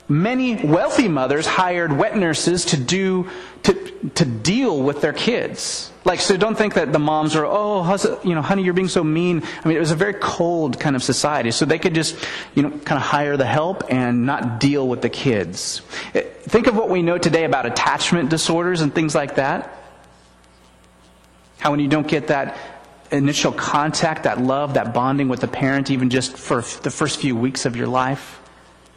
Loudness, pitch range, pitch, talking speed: -19 LUFS, 135-175 Hz, 150 Hz, 200 wpm